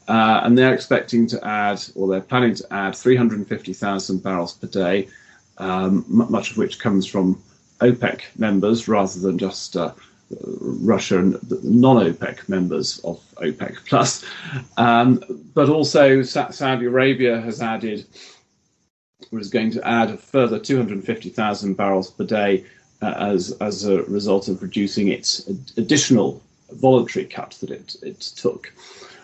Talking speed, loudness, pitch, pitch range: 145 wpm, -20 LUFS, 110 Hz, 95-125 Hz